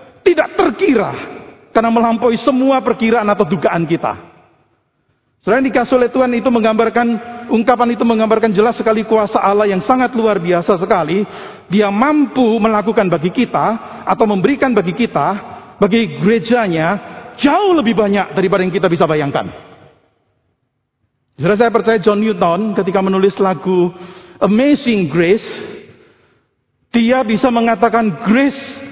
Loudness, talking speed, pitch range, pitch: -14 LUFS, 125 wpm, 190-240 Hz, 220 Hz